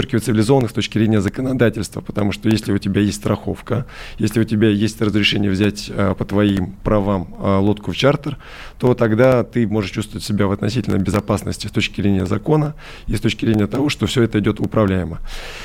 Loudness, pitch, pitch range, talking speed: -18 LUFS, 105 Hz, 100-115 Hz, 180 wpm